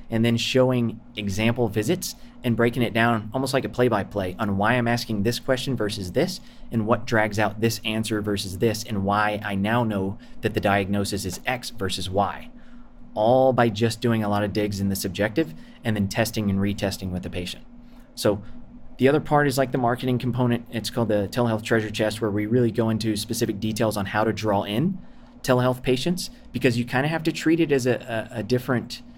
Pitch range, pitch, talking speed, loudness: 105-125 Hz, 115 Hz, 215 wpm, -24 LUFS